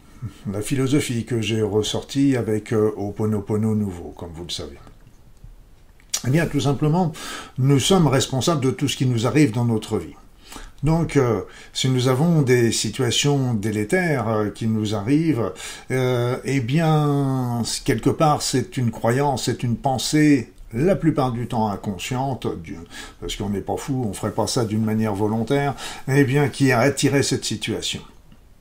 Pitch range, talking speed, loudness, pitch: 110-140 Hz, 155 wpm, -21 LUFS, 125 Hz